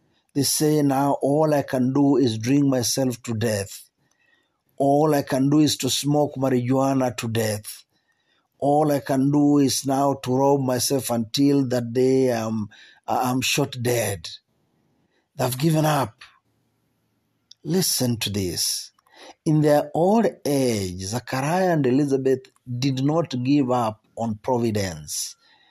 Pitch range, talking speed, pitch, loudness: 120-140 Hz, 135 wpm, 130 Hz, -22 LUFS